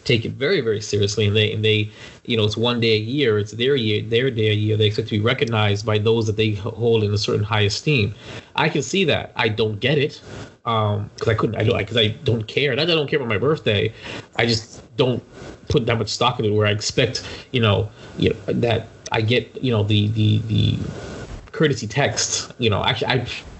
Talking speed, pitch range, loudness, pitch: 240 wpm, 105-120 Hz, -20 LUFS, 110 Hz